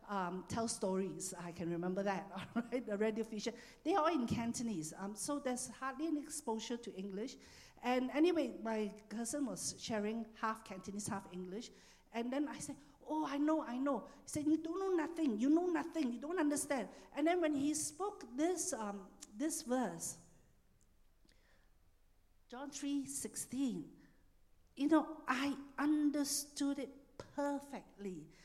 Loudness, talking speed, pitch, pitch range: -39 LUFS, 150 wpm, 255 Hz, 215-295 Hz